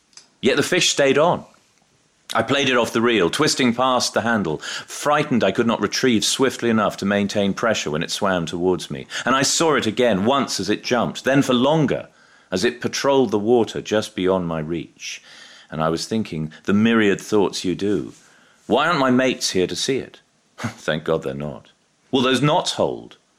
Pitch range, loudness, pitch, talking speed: 90-125 Hz, -20 LUFS, 105 Hz, 195 wpm